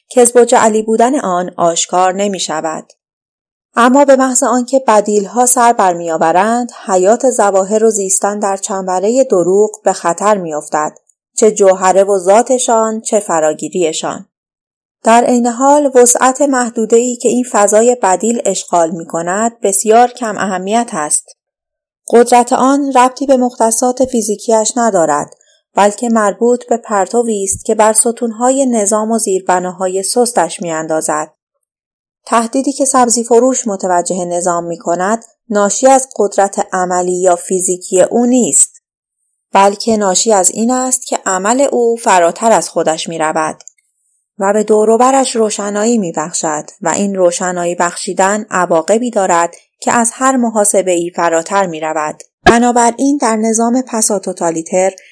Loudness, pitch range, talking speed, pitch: -12 LUFS, 185-240 Hz, 135 wpm, 215 Hz